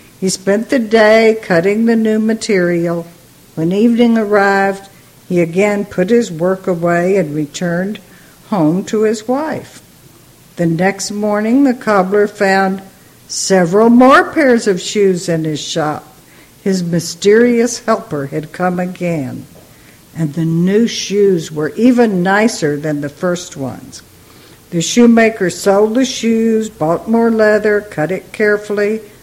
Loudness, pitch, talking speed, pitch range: -13 LUFS, 195 Hz, 135 wpm, 175-220 Hz